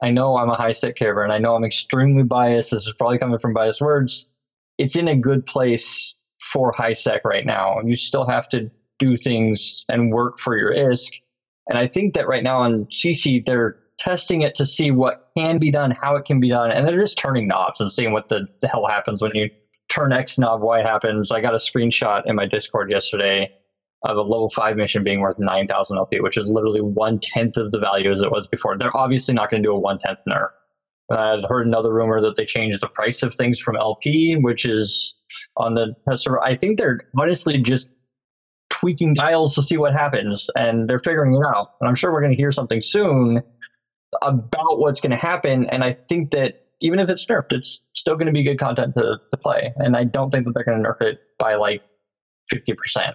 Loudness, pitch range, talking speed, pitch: -19 LUFS, 110-135 Hz, 230 wpm, 120 Hz